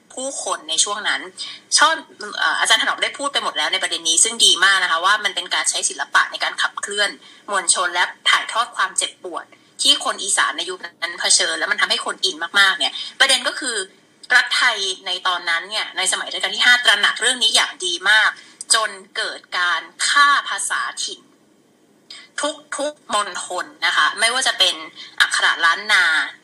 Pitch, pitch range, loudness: 270 Hz, 195-300 Hz, -17 LUFS